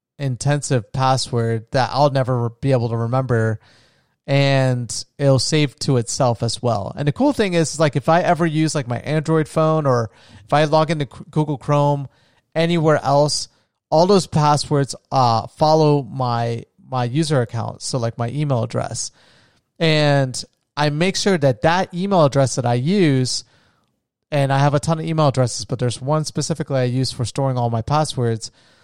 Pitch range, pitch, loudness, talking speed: 120-155 Hz, 140 Hz, -19 LUFS, 175 wpm